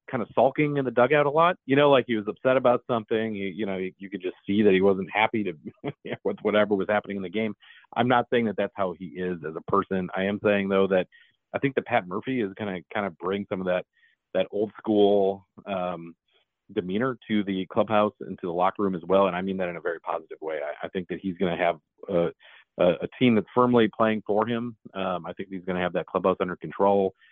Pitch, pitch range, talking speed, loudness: 100 Hz, 95-115 Hz, 255 wpm, -26 LUFS